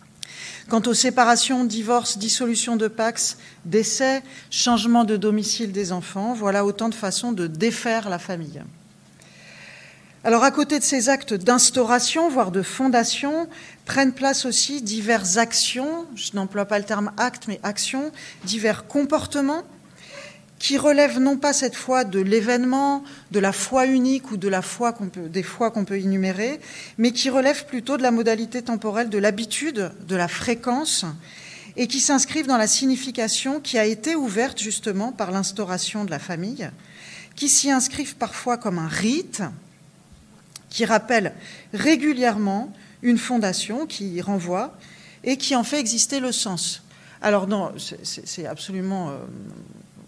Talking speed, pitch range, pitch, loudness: 150 wpm, 200-260 Hz, 230 Hz, -22 LUFS